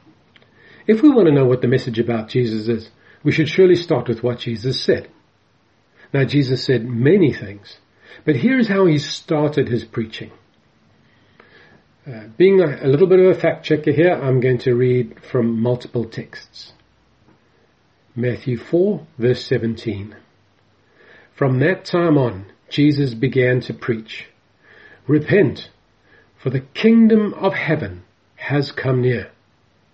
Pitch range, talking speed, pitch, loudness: 120-155 Hz, 140 wpm, 130 Hz, -18 LUFS